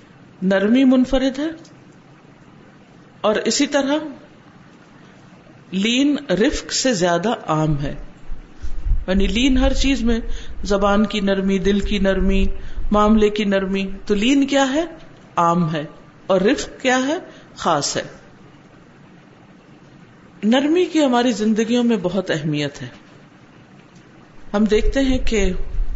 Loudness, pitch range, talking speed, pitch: -19 LUFS, 190-260 Hz, 115 wpm, 210 Hz